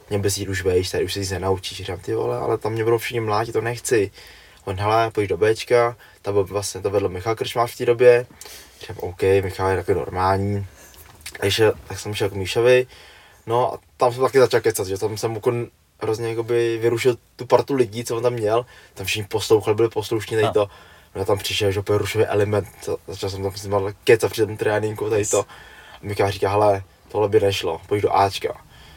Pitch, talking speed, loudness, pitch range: 105 Hz, 205 wpm, -21 LUFS, 100-120 Hz